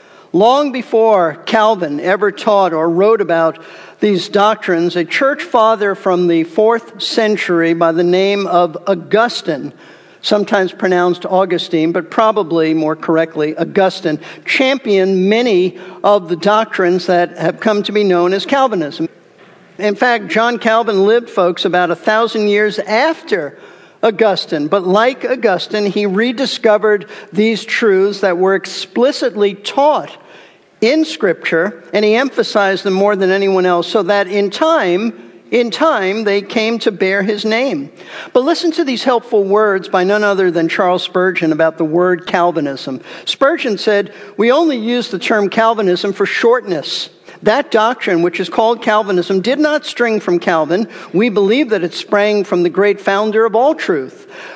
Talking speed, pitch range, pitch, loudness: 150 wpm, 180-225 Hz, 205 Hz, -14 LUFS